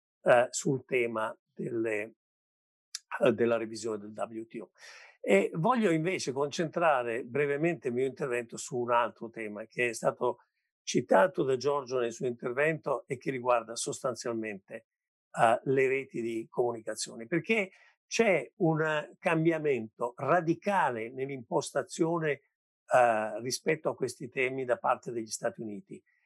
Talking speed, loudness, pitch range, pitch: 125 wpm, -30 LUFS, 115-160 Hz, 130 Hz